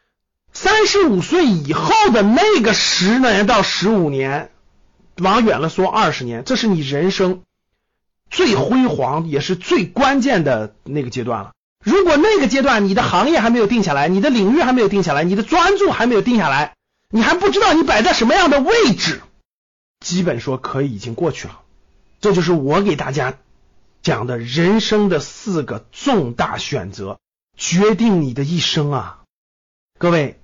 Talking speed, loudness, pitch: 250 characters per minute, -16 LUFS, 190 Hz